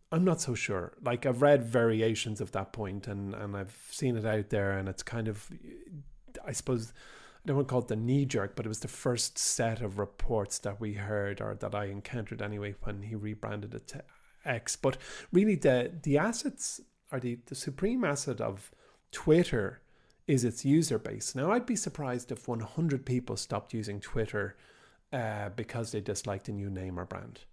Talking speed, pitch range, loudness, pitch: 195 wpm, 105-135 Hz, -32 LUFS, 115 Hz